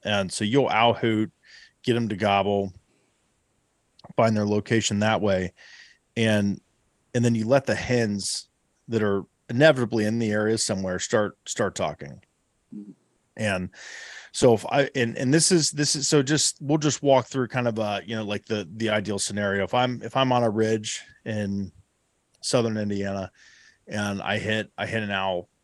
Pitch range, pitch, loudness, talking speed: 100-120 Hz, 110 Hz, -24 LUFS, 175 wpm